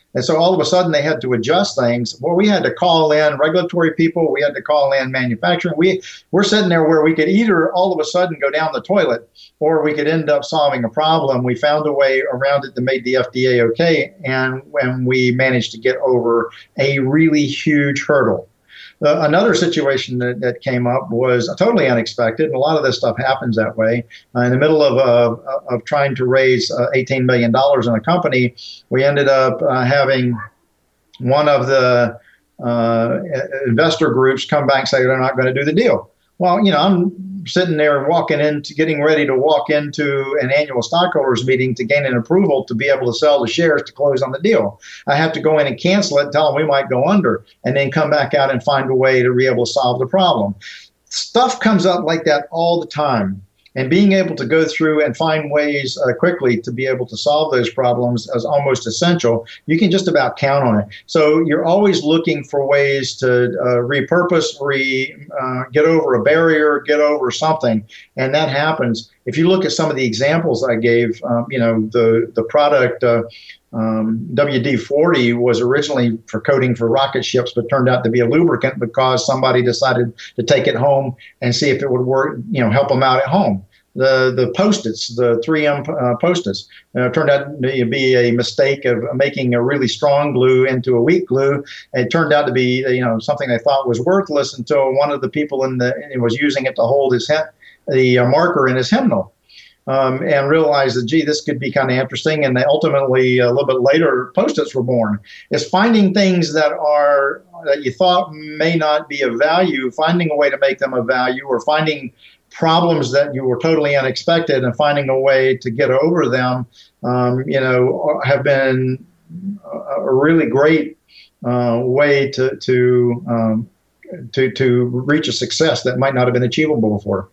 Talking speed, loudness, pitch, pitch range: 210 wpm, -16 LUFS, 135 Hz, 125-155 Hz